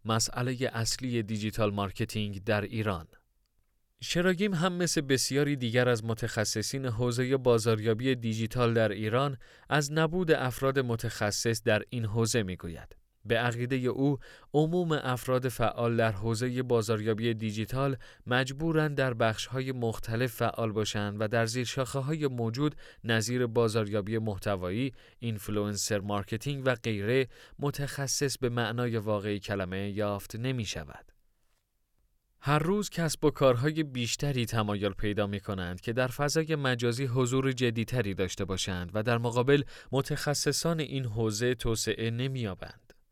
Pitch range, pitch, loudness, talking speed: 110-135 Hz, 120 Hz, -30 LUFS, 125 wpm